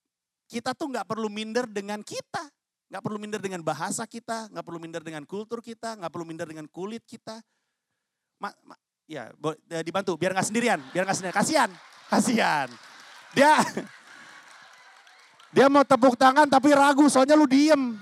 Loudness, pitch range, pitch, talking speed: -23 LUFS, 185-265 Hz, 220 Hz, 155 wpm